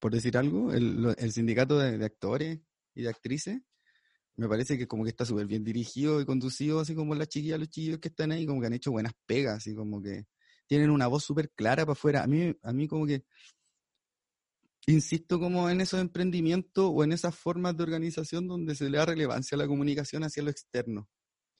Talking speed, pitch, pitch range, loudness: 210 wpm, 145 Hz, 120-160 Hz, -30 LUFS